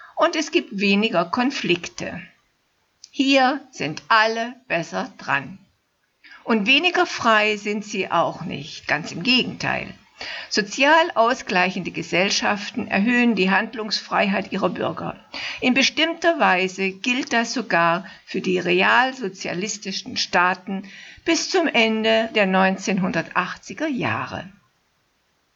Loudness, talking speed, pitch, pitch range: -20 LUFS, 105 wpm, 220 Hz, 190-255 Hz